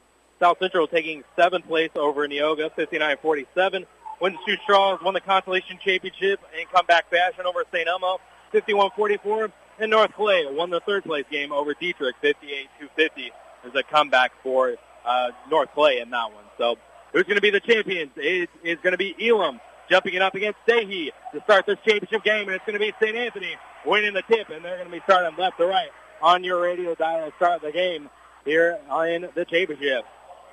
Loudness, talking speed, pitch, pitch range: -23 LUFS, 195 wpm, 185 Hz, 170-215 Hz